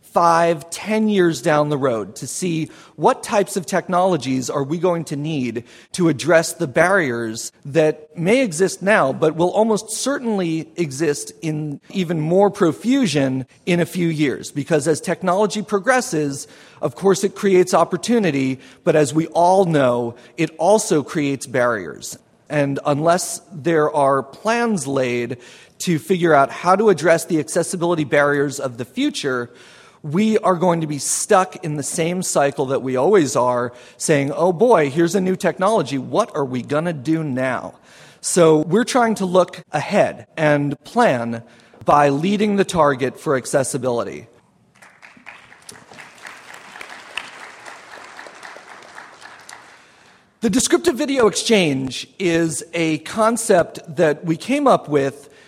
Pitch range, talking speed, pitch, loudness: 145-190 Hz, 140 wpm, 165 Hz, -19 LUFS